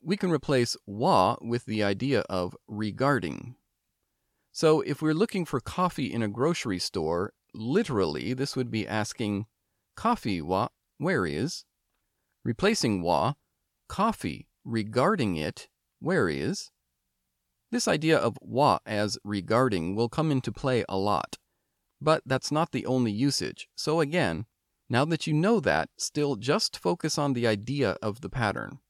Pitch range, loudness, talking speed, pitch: 105-140 Hz, -28 LUFS, 145 wpm, 120 Hz